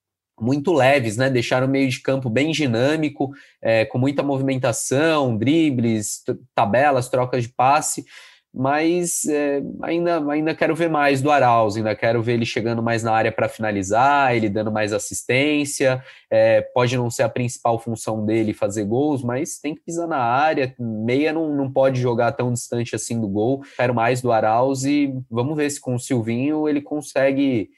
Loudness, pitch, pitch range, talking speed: -20 LUFS, 130 Hz, 115-145 Hz, 175 wpm